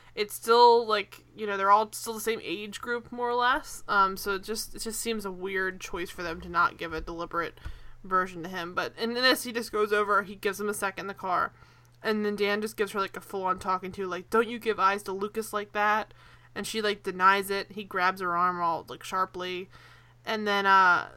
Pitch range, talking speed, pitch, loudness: 185-220 Hz, 245 wpm, 200 Hz, -28 LUFS